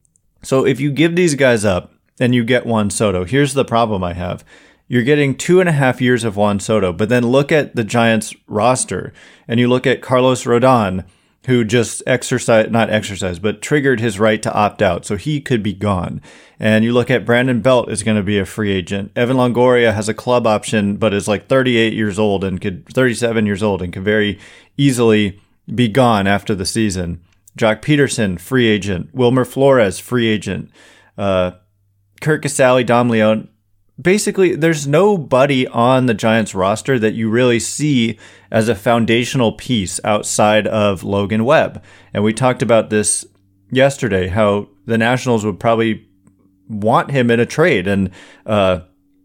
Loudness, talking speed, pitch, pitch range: -15 LUFS, 180 wpm, 110 Hz, 100-125 Hz